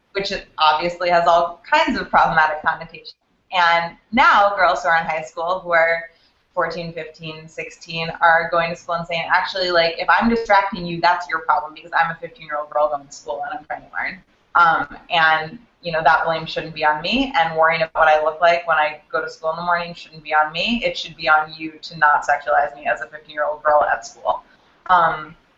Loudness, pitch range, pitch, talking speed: -18 LUFS, 155-175 Hz, 165 Hz, 230 wpm